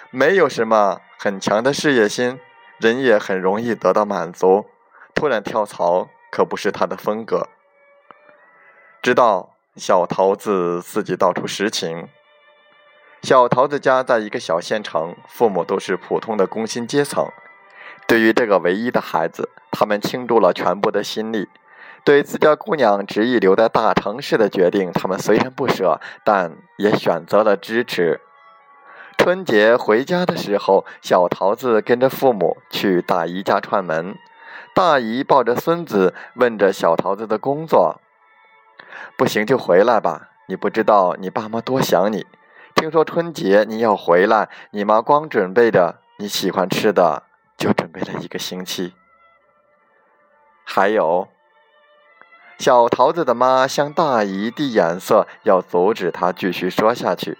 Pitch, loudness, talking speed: 130 Hz, -18 LUFS, 215 characters per minute